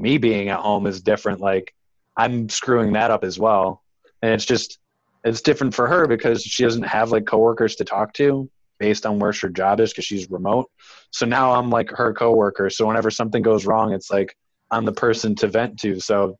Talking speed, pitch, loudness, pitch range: 210 wpm, 110 Hz, -20 LUFS, 100-115 Hz